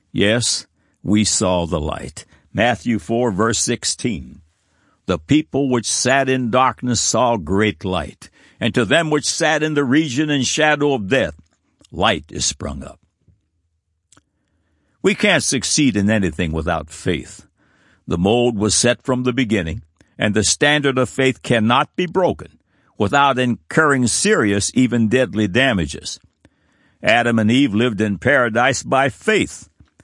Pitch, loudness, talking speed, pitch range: 110 Hz, -17 LUFS, 140 wpm, 90-130 Hz